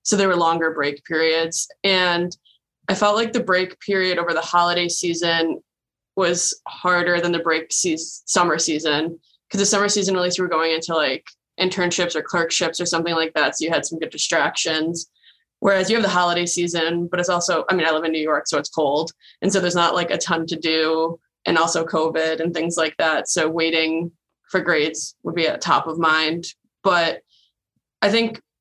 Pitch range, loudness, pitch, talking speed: 160-180 Hz, -20 LUFS, 170 Hz, 205 wpm